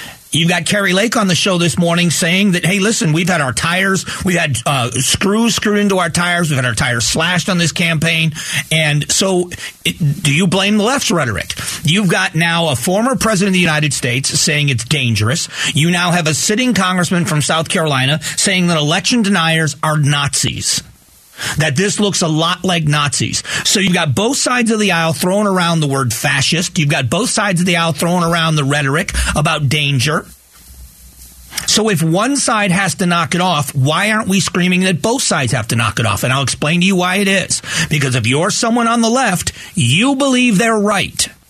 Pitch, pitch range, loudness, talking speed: 170 Hz, 150-195 Hz, -14 LUFS, 205 wpm